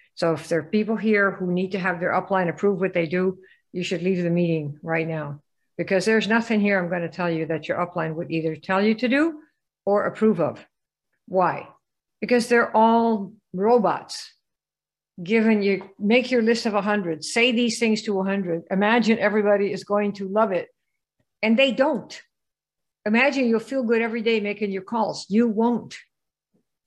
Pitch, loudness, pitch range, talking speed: 205 Hz, -22 LUFS, 180-230 Hz, 185 wpm